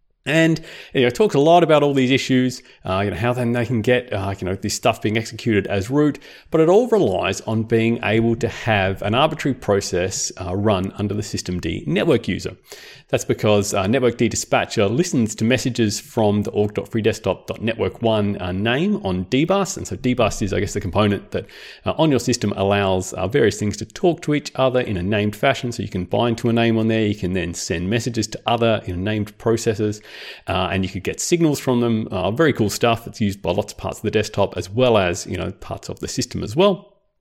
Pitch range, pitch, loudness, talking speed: 100-125 Hz, 110 Hz, -20 LUFS, 215 wpm